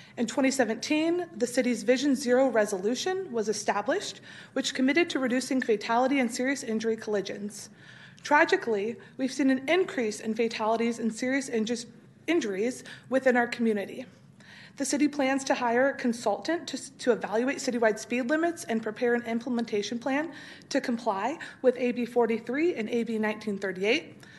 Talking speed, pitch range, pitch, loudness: 140 wpm, 225-270 Hz, 245 Hz, -28 LUFS